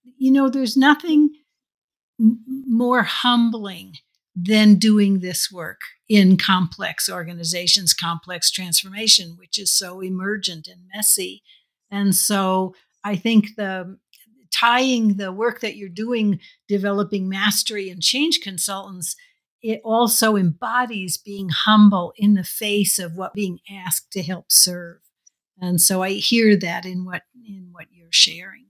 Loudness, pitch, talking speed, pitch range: -18 LUFS, 200 Hz, 130 wpm, 180-220 Hz